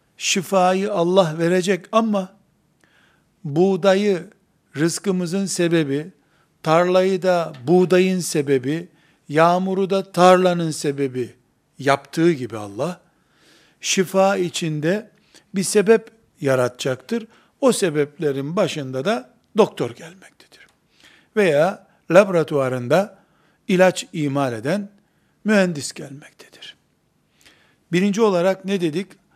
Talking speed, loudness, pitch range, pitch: 80 wpm, -20 LUFS, 155-195 Hz, 175 Hz